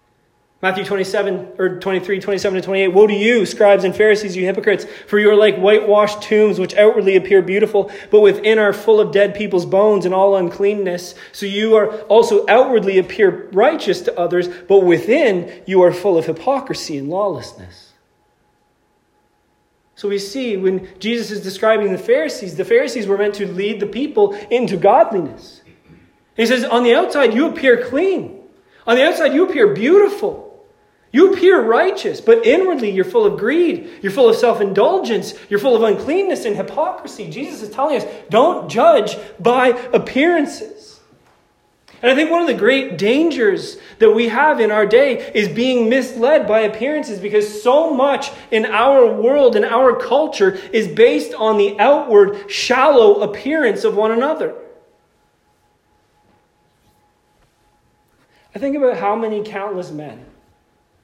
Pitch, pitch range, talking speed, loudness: 220 Hz, 200-315 Hz, 155 wpm, -15 LUFS